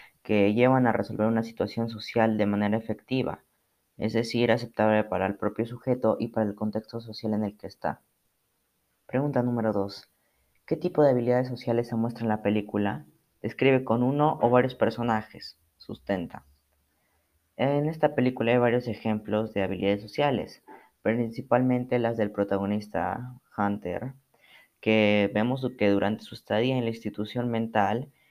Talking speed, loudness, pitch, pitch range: 150 wpm, -27 LUFS, 110 Hz, 105-120 Hz